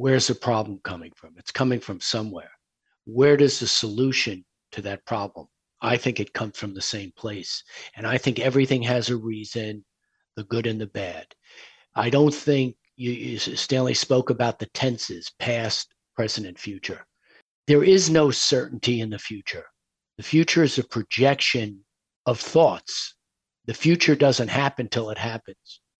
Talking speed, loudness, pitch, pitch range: 165 wpm, -23 LUFS, 120 Hz, 110-135 Hz